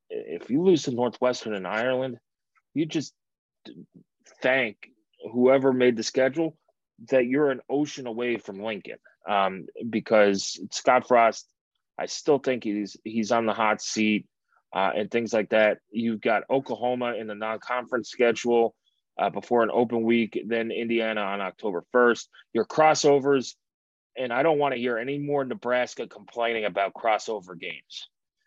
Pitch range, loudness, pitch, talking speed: 110-130 Hz, -25 LUFS, 120 Hz, 150 wpm